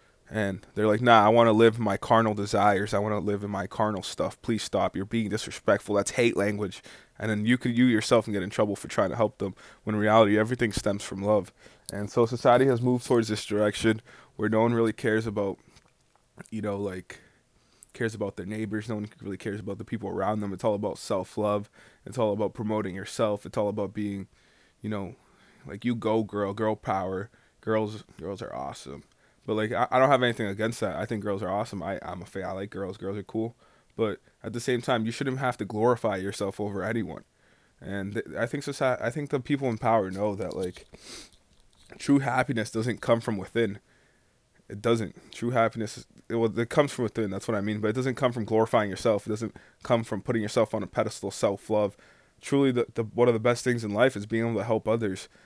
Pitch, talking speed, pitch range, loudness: 110 Hz, 225 wpm, 100-115 Hz, -27 LUFS